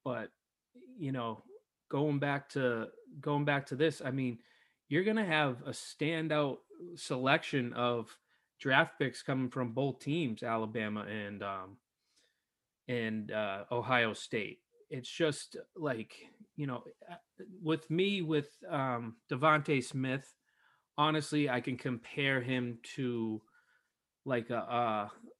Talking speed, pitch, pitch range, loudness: 125 wpm, 135 Hz, 120-150 Hz, -35 LUFS